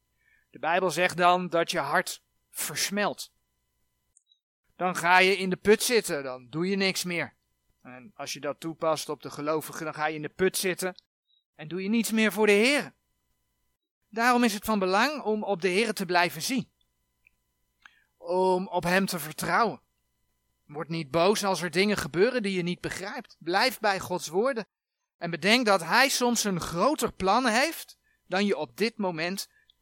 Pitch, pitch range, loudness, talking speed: 185 Hz, 165-215 Hz, -26 LUFS, 180 wpm